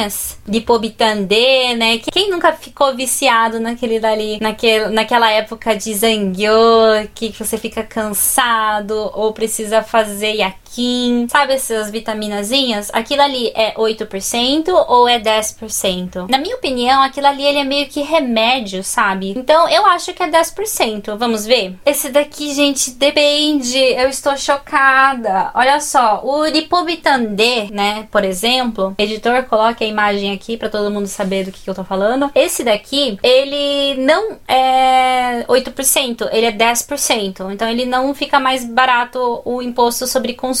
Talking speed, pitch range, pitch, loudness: 145 wpm, 220-275 Hz, 240 Hz, -15 LUFS